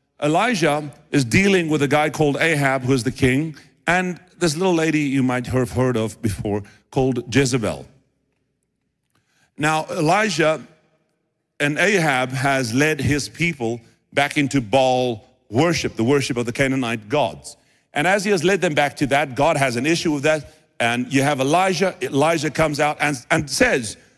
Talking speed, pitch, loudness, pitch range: 165 wpm, 145 Hz, -20 LUFS, 130-155 Hz